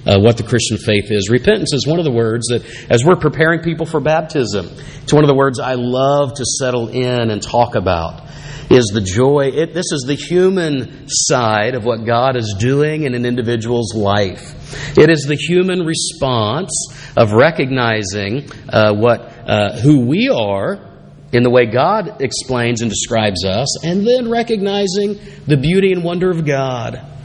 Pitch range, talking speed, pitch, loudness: 115-155 Hz, 175 wpm, 130 Hz, -15 LUFS